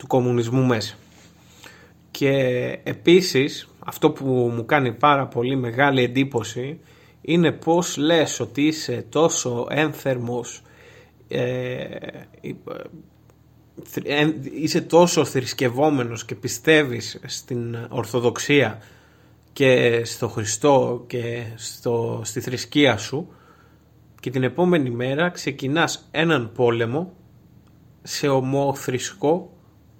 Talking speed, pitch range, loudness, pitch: 95 wpm, 120-150 Hz, -21 LUFS, 130 Hz